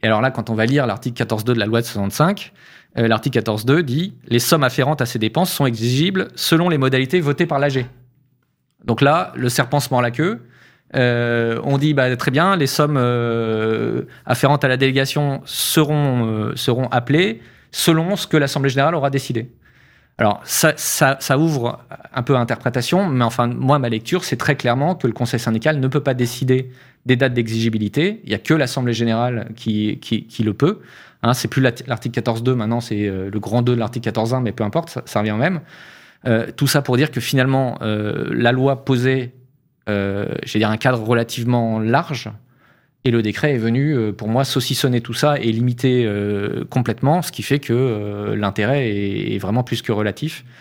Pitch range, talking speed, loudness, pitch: 115-140 Hz, 195 wpm, -19 LUFS, 125 Hz